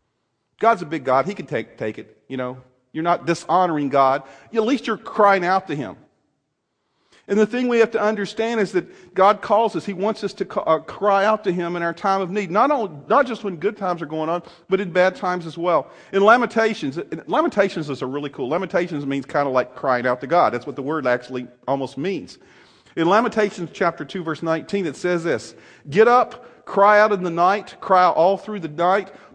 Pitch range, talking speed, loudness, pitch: 155-205 Hz, 225 wpm, -20 LUFS, 180 Hz